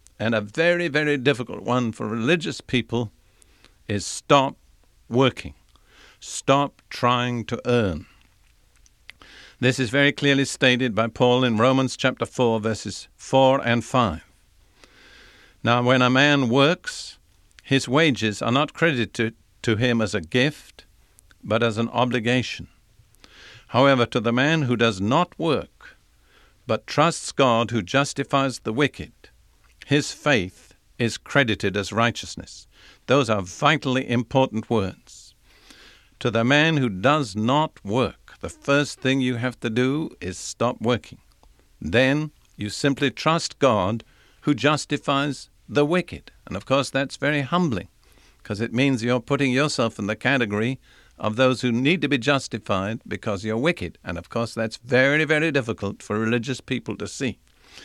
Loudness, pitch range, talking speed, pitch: -22 LUFS, 110-140 Hz, 145 wpm, 125 Hz